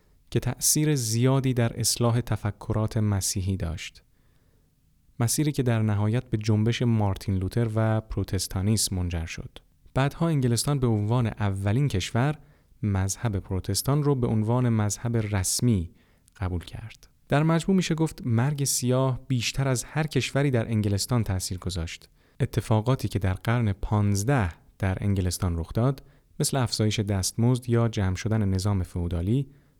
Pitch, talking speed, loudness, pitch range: 115 Hz, 135 wpm, -26 LUFS, 100-130 Hz